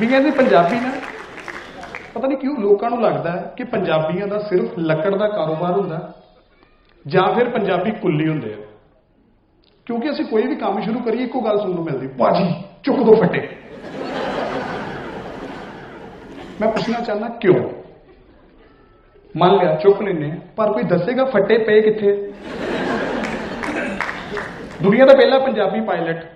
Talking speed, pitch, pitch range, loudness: 135 wpm, 205 Hz, 175-235 Hz, -18 LUFS